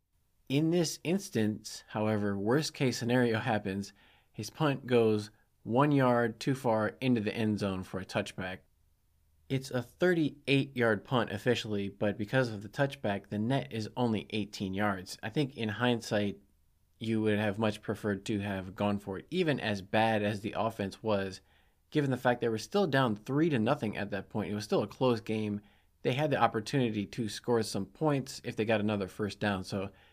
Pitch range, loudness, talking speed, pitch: 100-125 Hz, -32 LUFS, 185 wpm, 110 Hz